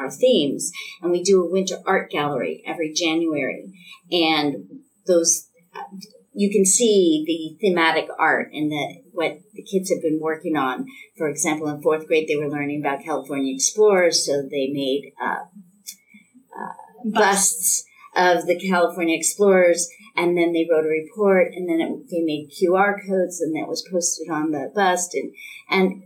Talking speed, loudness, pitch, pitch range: 165 wpm, -21 LUFS, 170 Hz, 155-195 Hz